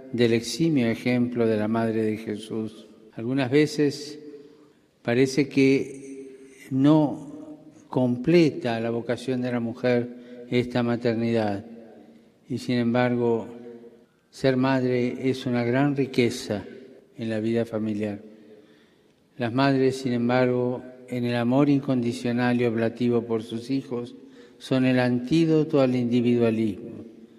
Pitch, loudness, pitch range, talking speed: 125 Hz, -24 LUFS, 115-130 Hz, 115 wpm